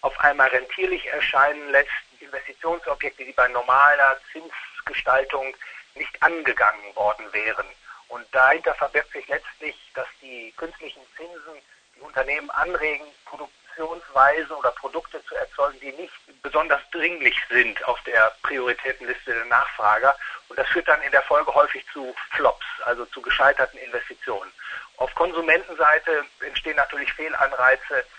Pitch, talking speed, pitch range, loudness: 145 Hz, 130 wpm, 135-165 Hz, -21 LUFS